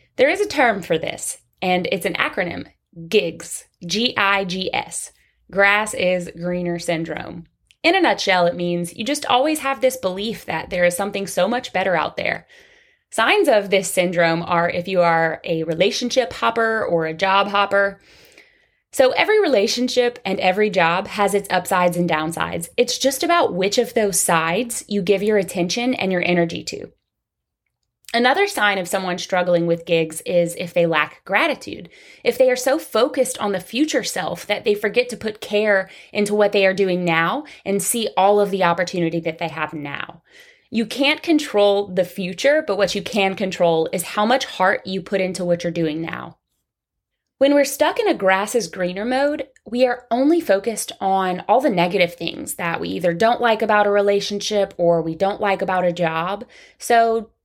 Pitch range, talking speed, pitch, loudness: 175-235 Hz, 185 wpm, 195 Hz, -19 LUFS